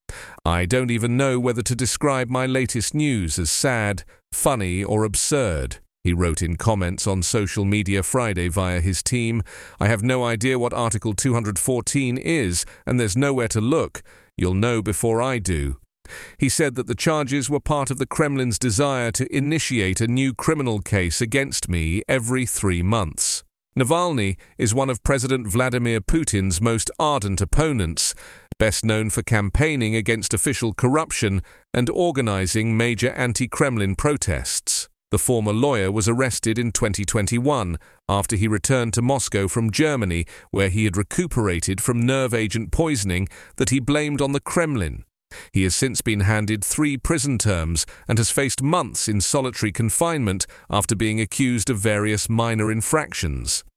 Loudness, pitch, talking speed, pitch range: -21 LUFS, 115 Hz, 155 wpm, 100-130 Hz